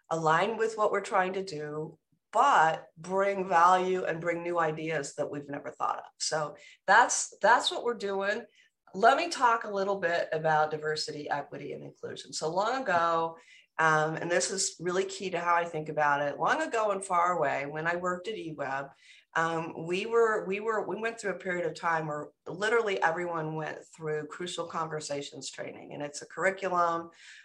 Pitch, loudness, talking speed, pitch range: 170 Hz, -29 LUFS, 185 wpm, 155-195 Hz